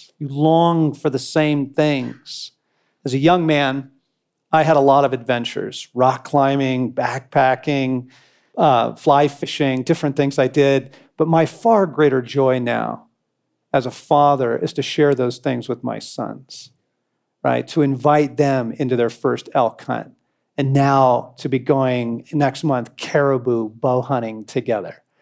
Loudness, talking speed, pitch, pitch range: -18 LUFS, 150 wpm, 140 Hz, 130-150 Hz